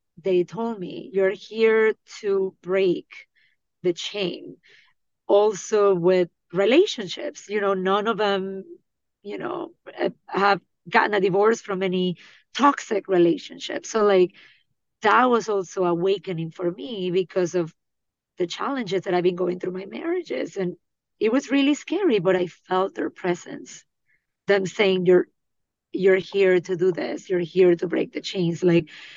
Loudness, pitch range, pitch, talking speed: -23 LUFS, 180-220 Hz, 195 Hz, 145 wpm